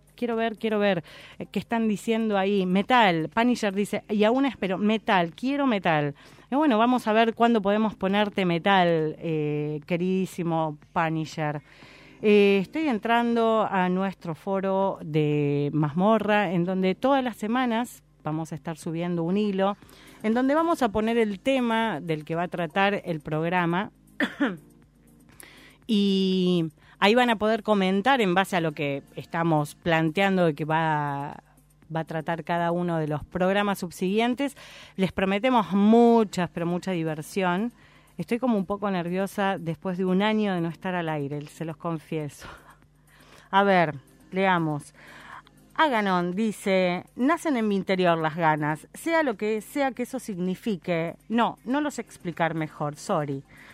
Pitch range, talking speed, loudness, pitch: 165-220 Hz, 150 wpm, -25 LUFS, 190 Hz